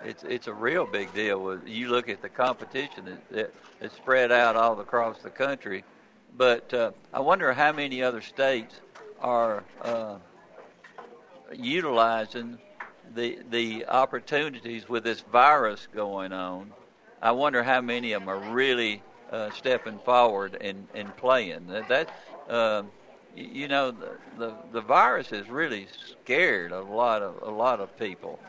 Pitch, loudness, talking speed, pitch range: 120 Hz, -26 LUFS, 150 wpm, 110-125 Hz